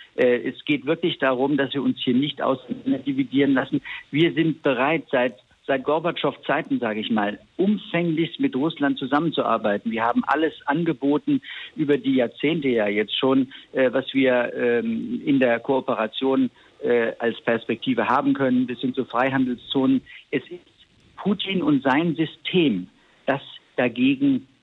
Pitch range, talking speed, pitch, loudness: 130-165 Hz, 135 wpm, 140 Hz, -23 LUFS